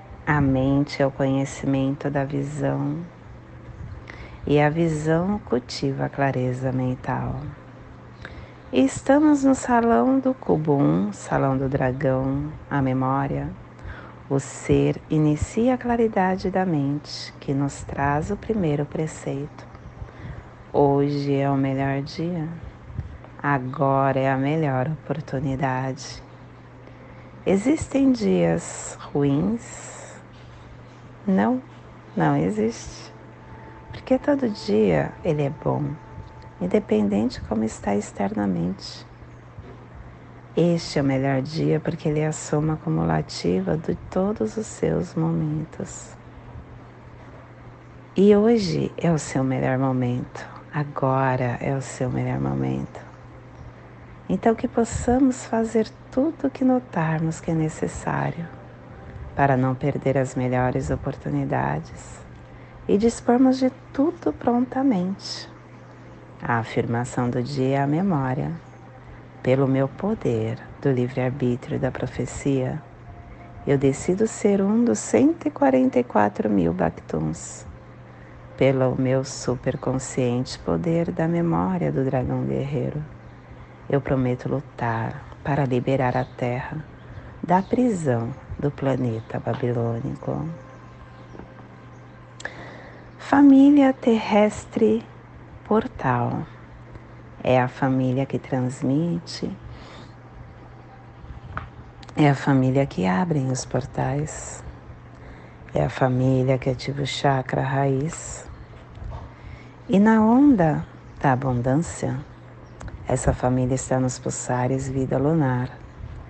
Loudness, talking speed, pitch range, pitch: -23 LUFS, 100 wpm, 125-165 Hz, 135 Hz